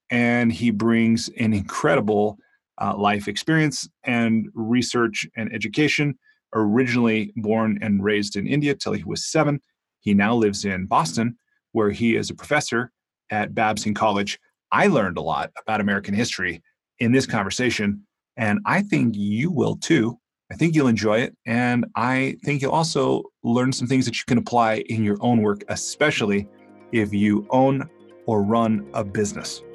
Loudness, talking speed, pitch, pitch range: -22 LUFS, 160 wpm, 115 Hz, 105-130 Hz